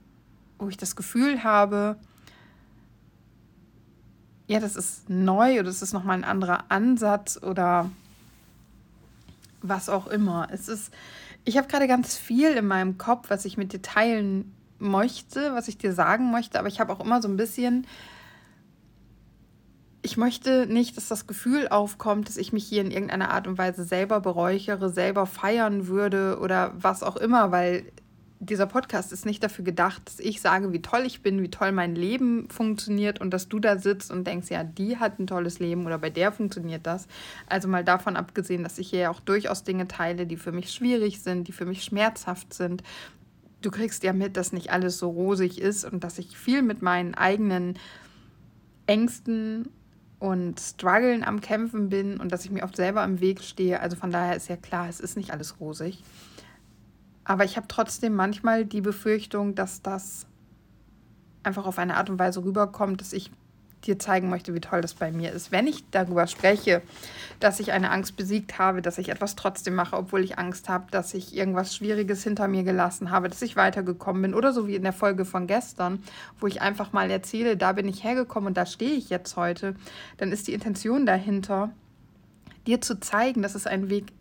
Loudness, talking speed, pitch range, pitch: -26 LUFS, 190 wpm, 185-215 Hz, 195 Hz